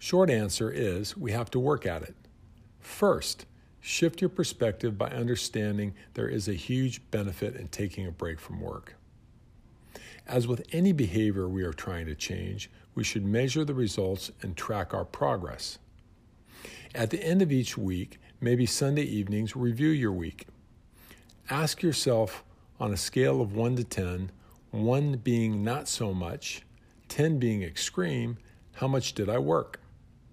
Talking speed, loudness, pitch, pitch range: 155 wpm, -30 LUFS, 115 Hz, 100-125 Hz